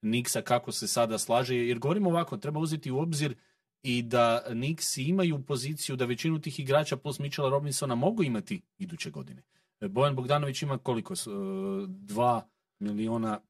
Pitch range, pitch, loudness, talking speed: 120-175 Hz, 145 Hz, -30 LUFS, 150 wpm